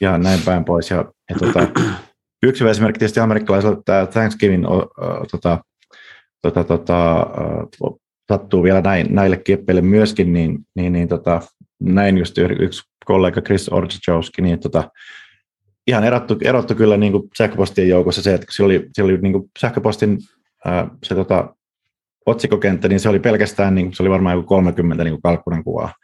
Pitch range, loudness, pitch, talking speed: 85-105 Hz, -17 LUFS, 95 Hz, 160 wpm